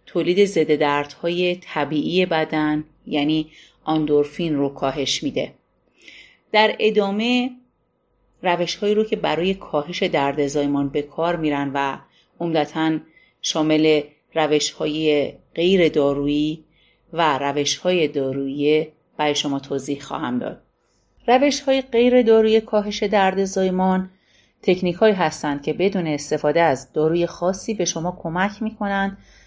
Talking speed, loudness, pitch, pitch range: 120 wpm, -21 LUFS, 160 Hz, 150-190 Hz